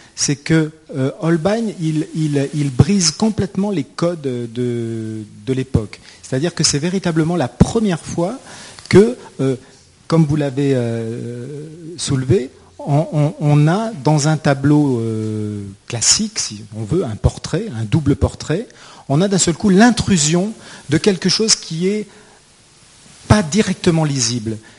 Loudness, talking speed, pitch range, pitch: -17 LUFS, 145 wpm, 125-180 Hz, 150 Hz